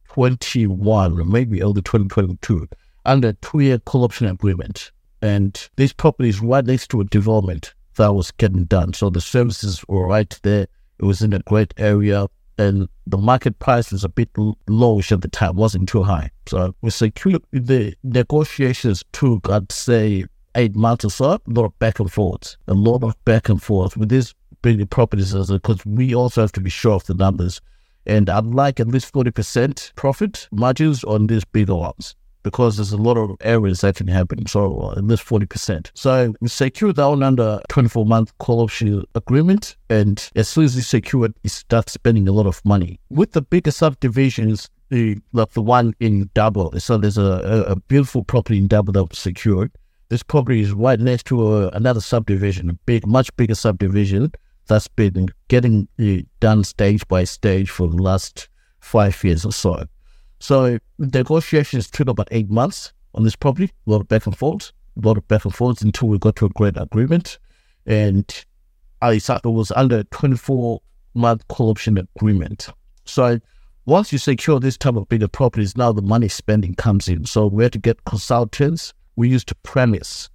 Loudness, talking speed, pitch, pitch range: -18 LUFS, 185 wpm, 110 Hz, 100-125 Hz